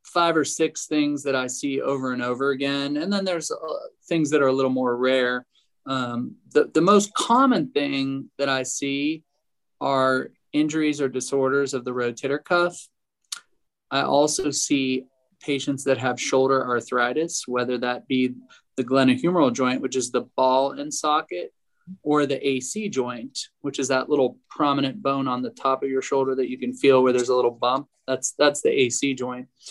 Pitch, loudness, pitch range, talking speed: 135 Hz, -23 LUFS, 130-145 Hz, 180 wpm